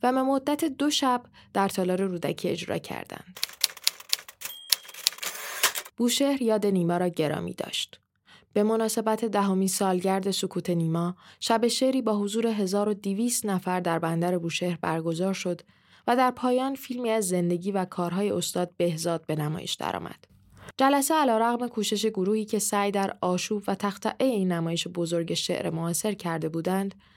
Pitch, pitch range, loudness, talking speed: 195 Hz, 175-230 Hz, -27 LUFS, 140 wpm